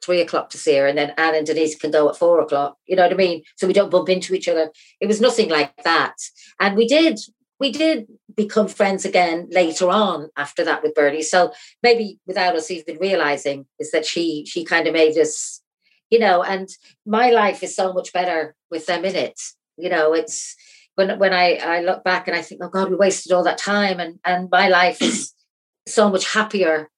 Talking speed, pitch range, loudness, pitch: 220 wpm, 160-200 Hz, -19 LUFS, 180 Hz